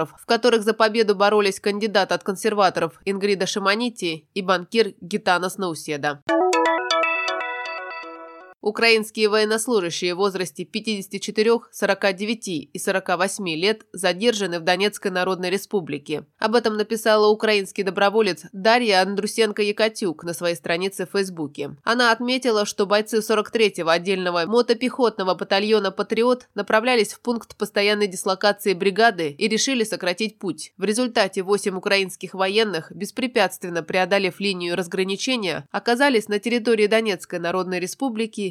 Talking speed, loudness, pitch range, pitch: 115 wpm, -21 LUFS, 185-220 Hz, 200 Hz